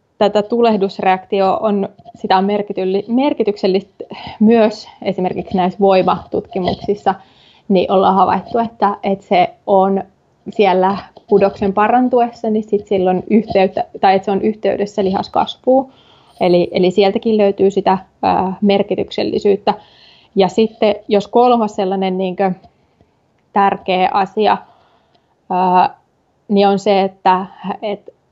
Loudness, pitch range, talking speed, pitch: -15 LUFS, 190-215 Hz, 105 wpm, 200 Hz